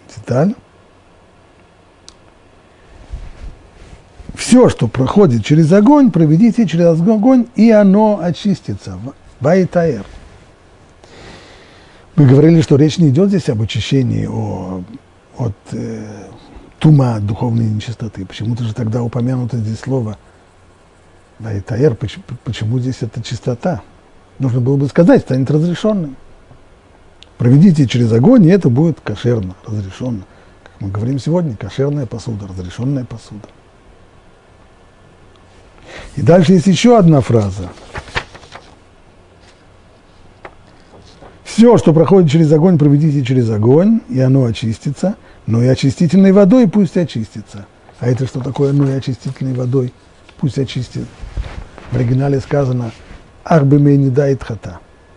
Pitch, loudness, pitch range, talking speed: 120 Hz, -13 LUFS, 95-150 Hz, 110 wpm